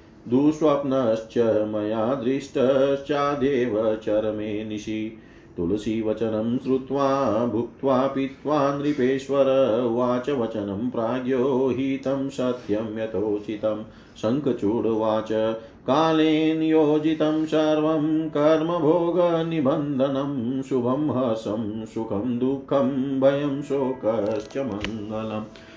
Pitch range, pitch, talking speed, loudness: 110-140 Hz, 130 Hz, 65 wpm, -24 LUFS